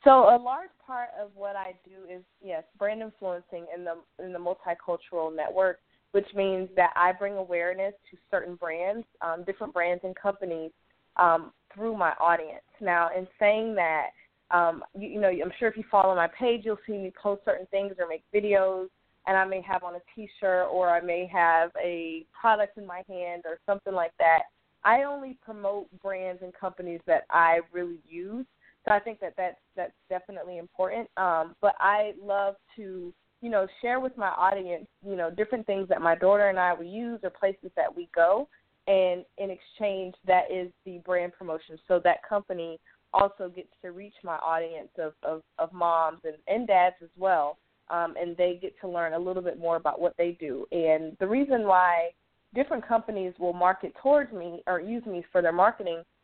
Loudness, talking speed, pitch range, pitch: -28 LUFS, 195 wpm, 175-200 Hz, 185 Hz